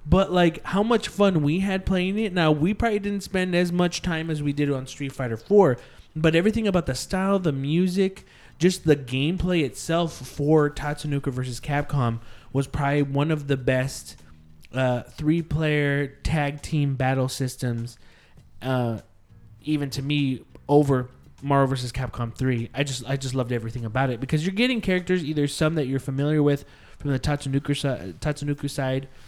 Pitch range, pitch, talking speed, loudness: 130-165 Hz, 145 Hz, 170 wpm, -24 LUFS